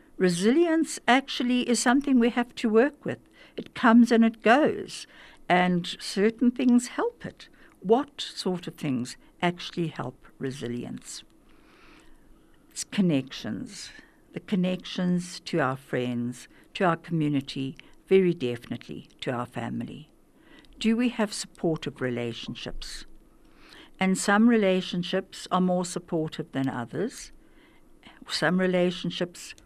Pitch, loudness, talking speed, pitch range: 190 Hz, -26 LUFS, 115 wpm, 170-255 Hz